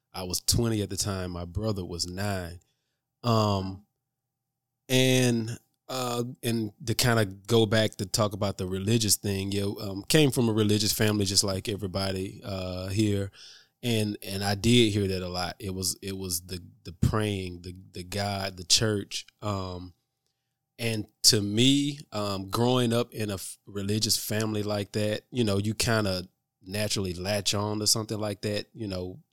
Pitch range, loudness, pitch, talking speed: 95-115 Hz, -27 LUFS, 105 Hz, 175 wpm